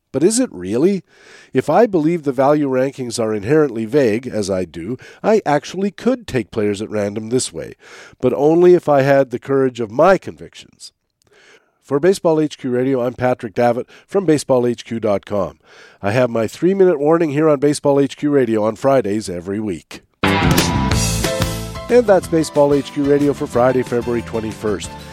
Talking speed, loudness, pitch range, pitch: 160 wpm, -17 LUFS, 115-150 Hz, 130 Hz